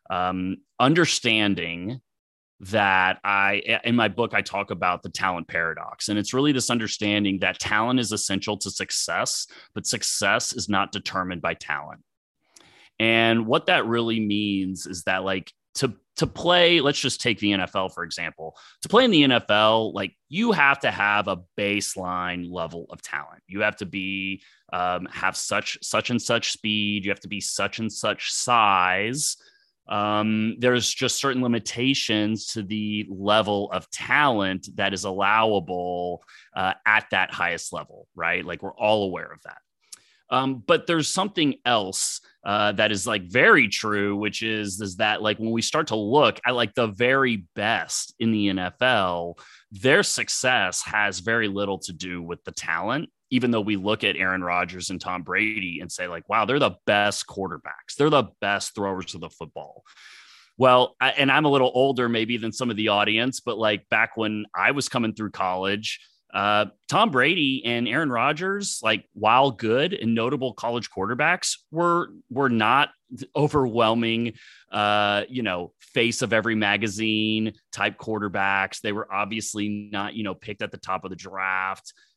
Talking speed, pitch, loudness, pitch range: 170 wpm, 105 Hz, -23 LUFS, 95-120 Hz